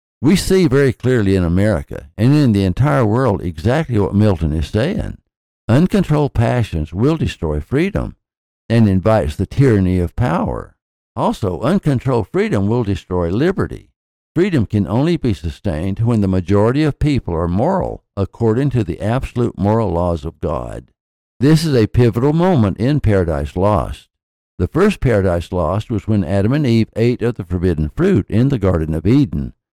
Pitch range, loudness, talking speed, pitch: 90-125 Hz, -16 LUFS, 160 wpm, 105 Hz